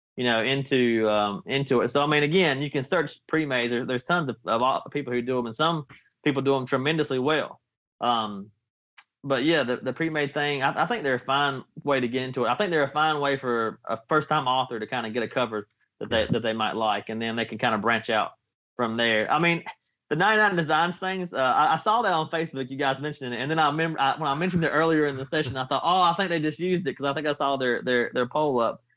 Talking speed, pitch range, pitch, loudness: 265 wpm, 120-155 Hz, 135 Hz, -25 LUFS